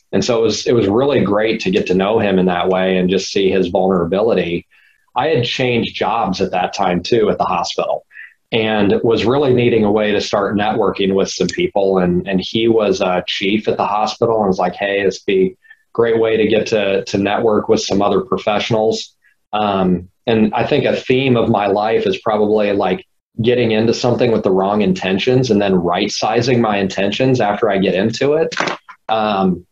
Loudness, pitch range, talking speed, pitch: -16 LUFS, 95-115 Hz, 205 wpm, 105 Hz